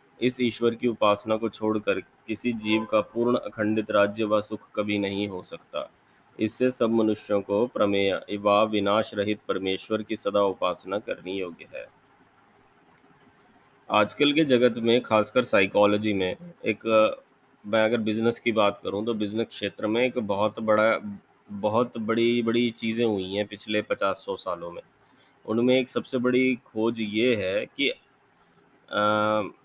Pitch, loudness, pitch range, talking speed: 110 Hz, -25 LUFS, 105-120 Hz, 150 wpm